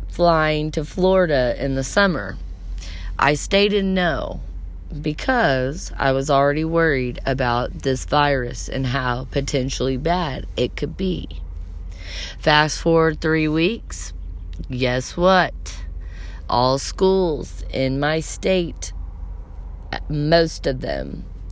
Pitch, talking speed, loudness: 135 Hz, 105 wpm, -20 LUFS